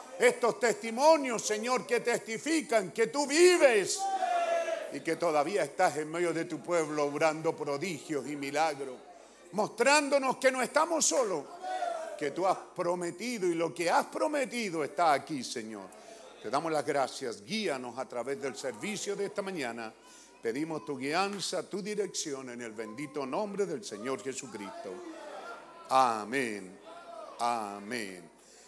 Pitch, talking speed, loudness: 200 Hz, 135 wpm, -31 LUFS